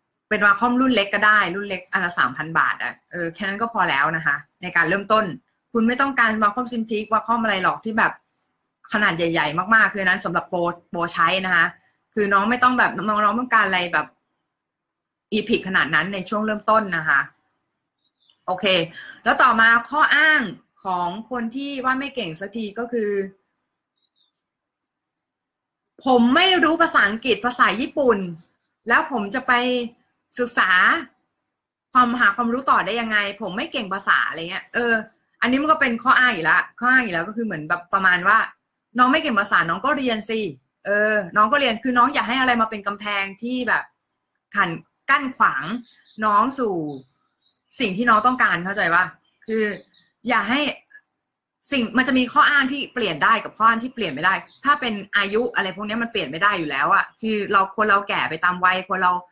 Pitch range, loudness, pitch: 195-245 Hz, -20 LUFS, 220 Hz